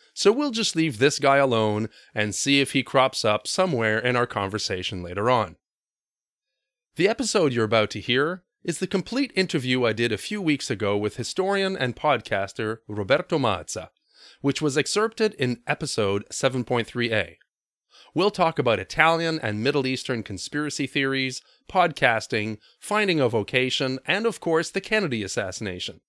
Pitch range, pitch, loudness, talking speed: 110-165 Hz, 135 Hz, -24 LUFS, 150 wpm